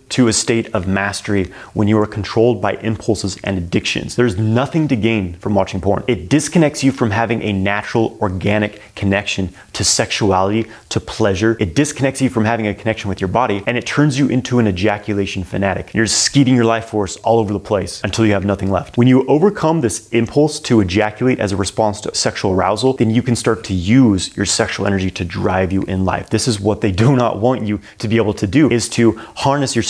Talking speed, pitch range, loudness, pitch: 220 wpm, 100-120 Hz, -16 LUFS, 110 Hz